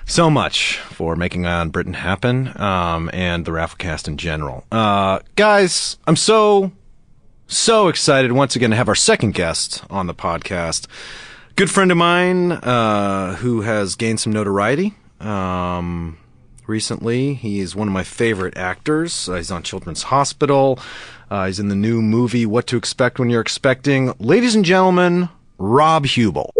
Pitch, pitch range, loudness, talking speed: 110 Hz, 90-140 Hz, -17 LUFS, 160 wpm